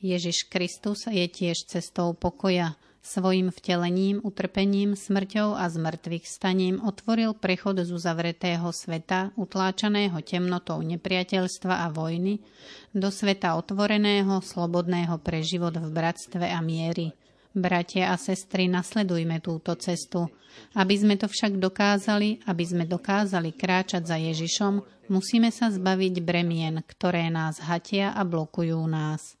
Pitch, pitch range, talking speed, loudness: 180 Hz, 170-195 Hz, 120 wpm, -27 LUFS